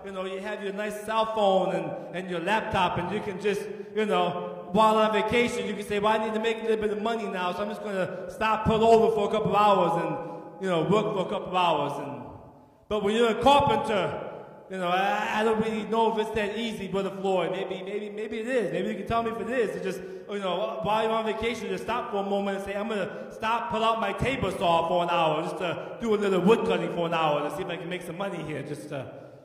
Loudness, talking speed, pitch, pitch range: -27 LUFS, 285 wpm, 200 Hz, 180-220 Hz